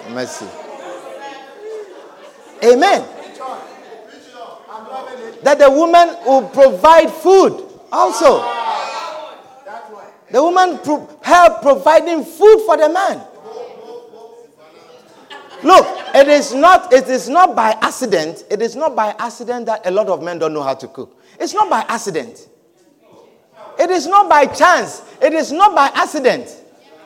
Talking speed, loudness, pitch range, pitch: 125 wpm, -13 LUFS, 245-350 Hz, 295 Hz